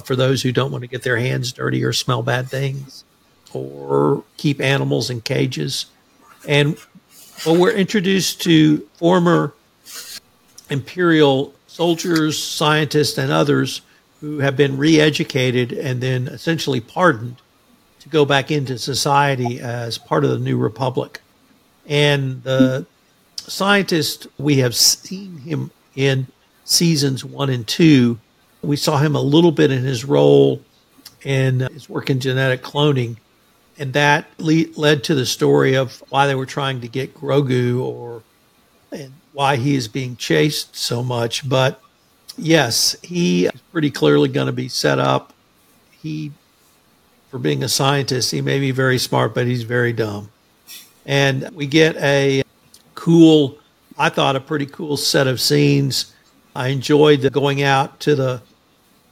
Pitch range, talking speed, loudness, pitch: 130-150 Hz, 150 wpm, -17 LUFS, 140 Hz